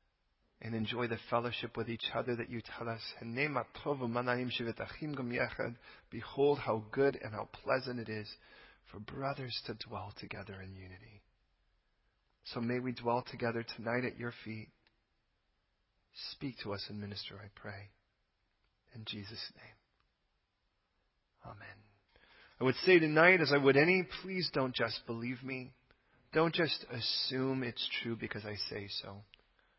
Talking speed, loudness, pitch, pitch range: 135 wpm, -35 LUFS, 120 Hz, 105-130 Hz